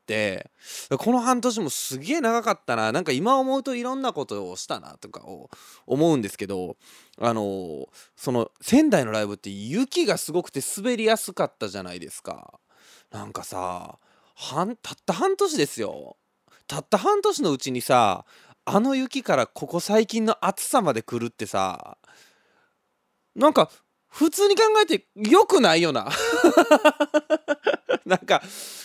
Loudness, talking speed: -23 LUFS, 285 characters per minute